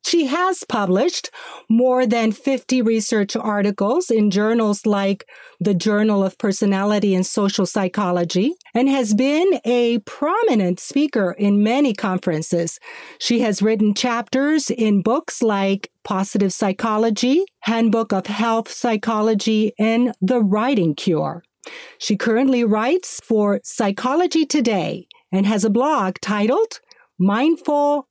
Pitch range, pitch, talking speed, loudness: 200-255 Hz, 220 Hz, 120 wpm, -19 LUFS